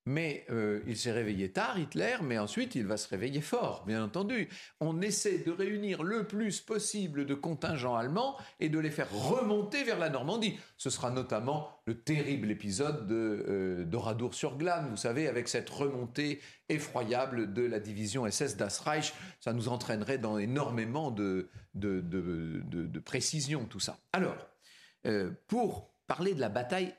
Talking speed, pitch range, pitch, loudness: 165 wpm, 110-165 Hz, 135 Hz, -34 LUFS